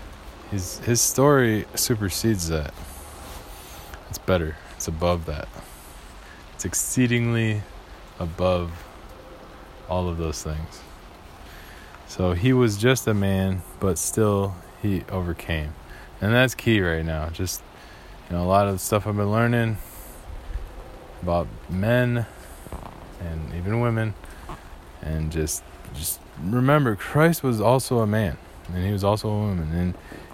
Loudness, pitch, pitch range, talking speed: -24 LUFS, 90 Hz, 80-105 Hz, 125 wpm